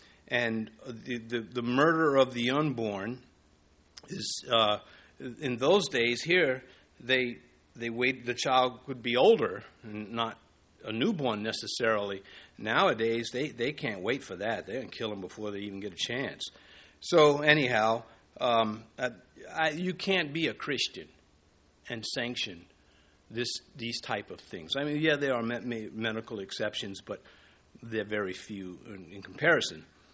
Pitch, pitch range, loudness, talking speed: 115 Hz, 100-125 Hz, -30 LUFS, 150 wpm